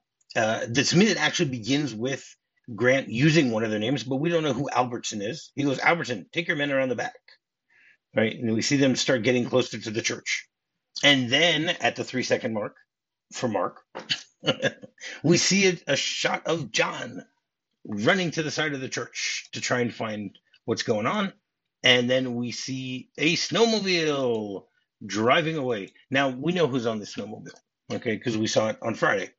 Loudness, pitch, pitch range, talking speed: -25 LUFS, 130 Hz, 120-155 Hz, 185 wpm